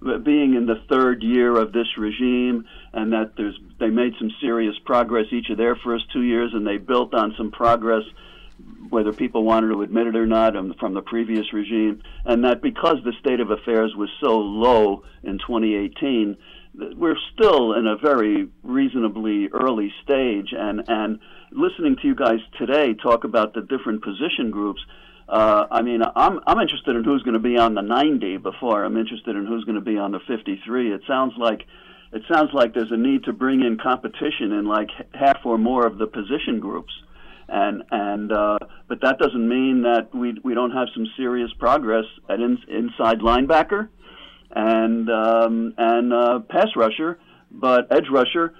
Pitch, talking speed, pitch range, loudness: 115 Hz, 185 wpm, 110-125 Hz, -21 LUFS